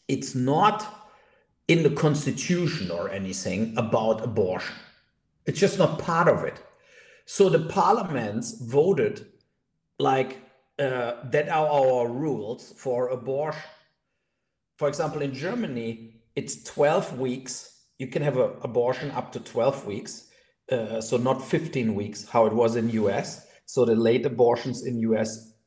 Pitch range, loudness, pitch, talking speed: 115-155 Hz, -25 LUFS, 130 Hz, 140 wpm